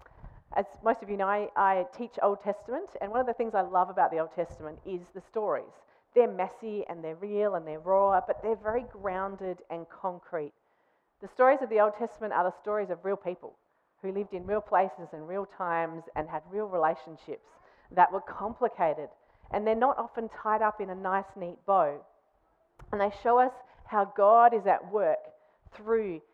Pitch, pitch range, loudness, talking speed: 200 Hz, 180-220 Hz, -29 LUFS, 195 wpm